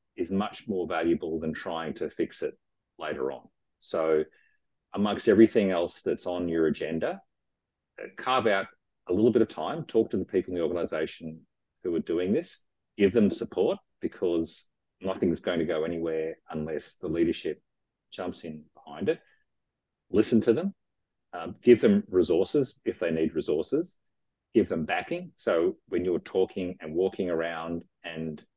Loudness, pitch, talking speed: -28 LUFS, 95 Hz, 160 wpm